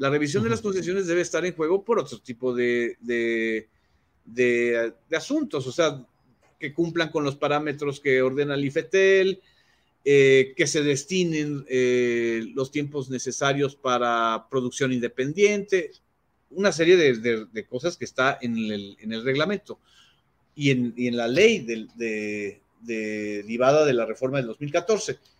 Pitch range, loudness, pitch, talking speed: 120-165 Hz, -24 LUFS, 135 Hz, 160 wpm